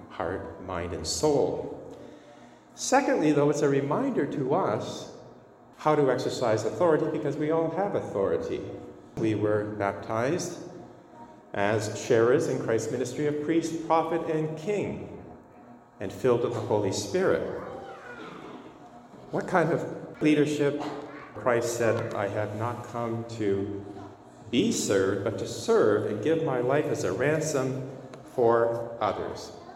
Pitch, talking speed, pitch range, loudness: 130 Hz, 130 wpm, 105-155 Hz, -27 LUFS